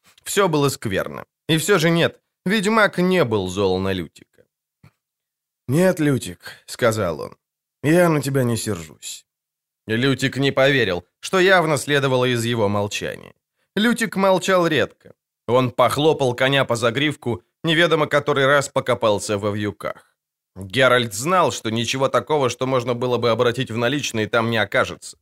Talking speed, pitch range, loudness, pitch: 145 wpm, 115-160 Hz, -19 LUFS, 135 Hz